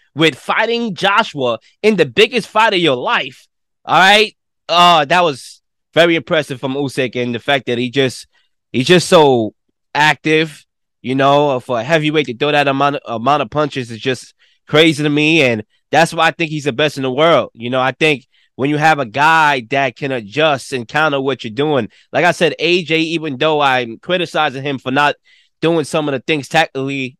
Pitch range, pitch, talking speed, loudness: 135-160 Hz, 150 Hz, 205 wpm, -14 LUFS